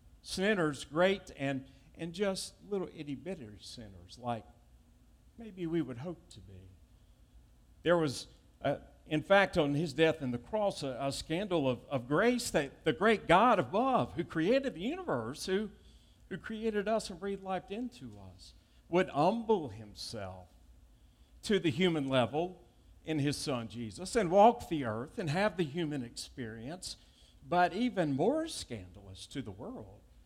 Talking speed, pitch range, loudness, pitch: 155 wpm, 120-190 Hz, -33 LUFS, 155 Hz